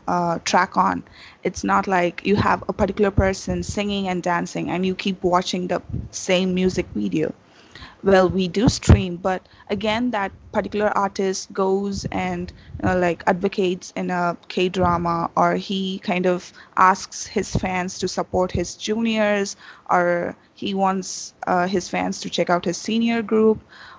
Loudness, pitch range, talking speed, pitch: -22 LUFS, 180-200 Hz, 160 wpm, 185 Hz